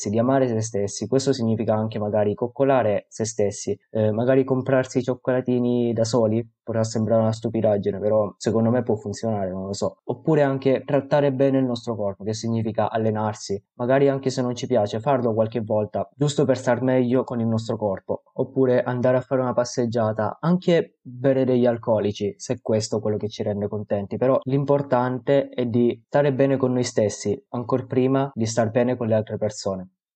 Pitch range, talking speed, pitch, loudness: 110-130 Hz, 185 wpm, 120 Hz, -23 LUFS